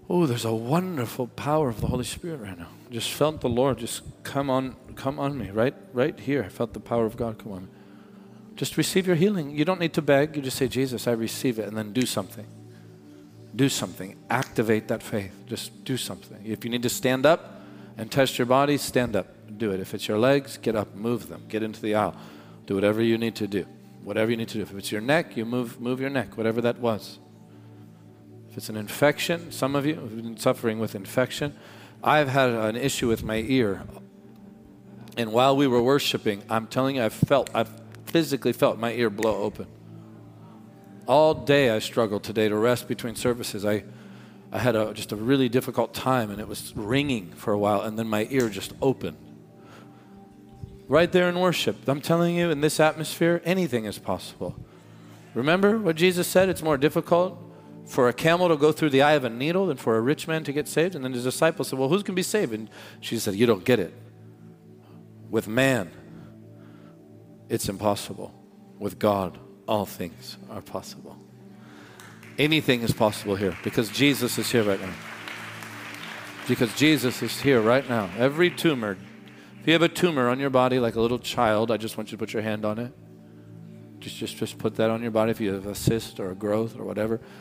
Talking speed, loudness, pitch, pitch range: 205 wpm, -25 LUFS, 120 Hz, 110-140 Hz